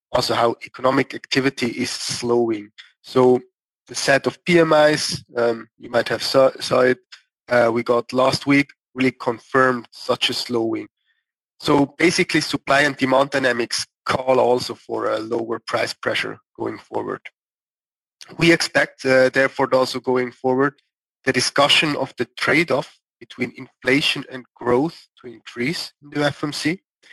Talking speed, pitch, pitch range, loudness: 140 wpm, 130 Hz, 125-145 Hz, -20 LUFS